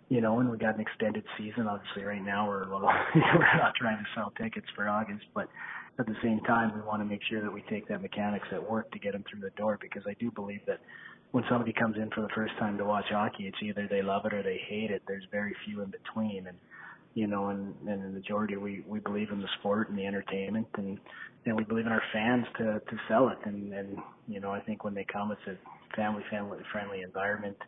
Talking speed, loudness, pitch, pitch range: 255 wpm, -32 LUFS, 105 Hz, 100-110 Hz